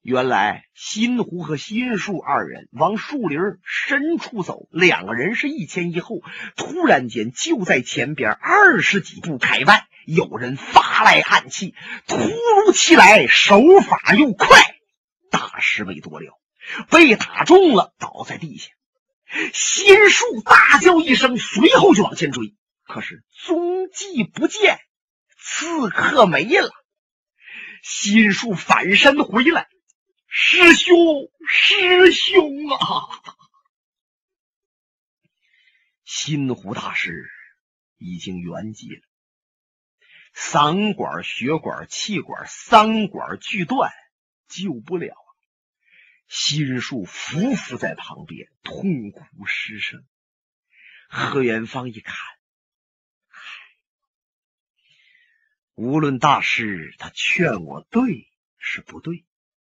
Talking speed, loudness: 145 characters per minute, -15 LUFS